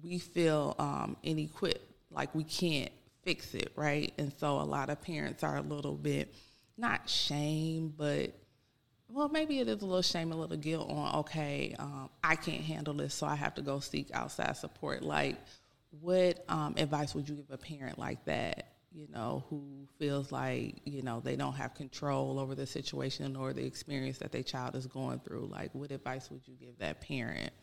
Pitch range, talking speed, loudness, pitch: 130-155 Hz, 195 wpm, -36 LUFS, 145 Hz